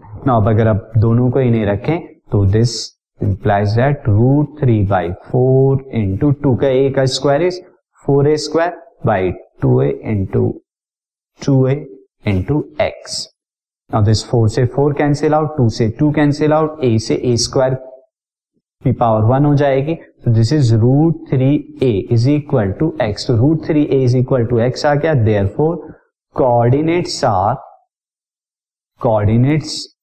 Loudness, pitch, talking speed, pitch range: -15 LUFS, 130 Hz, 135 wpm, 115-150 Hz